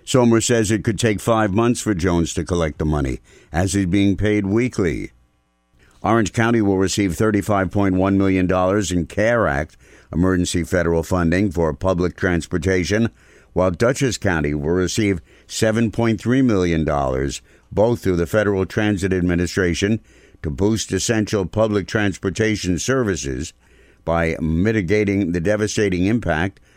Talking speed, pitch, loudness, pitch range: 130 wpm, 95 Hz, -19 LUFS, 85-110 Hz